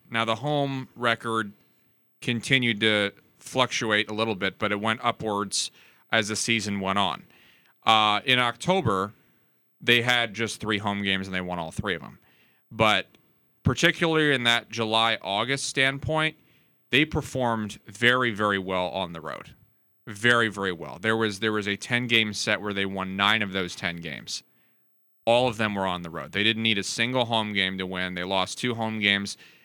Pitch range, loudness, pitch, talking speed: 100-120 Hz, -25 LUFS, 110 Hz, 180 wpm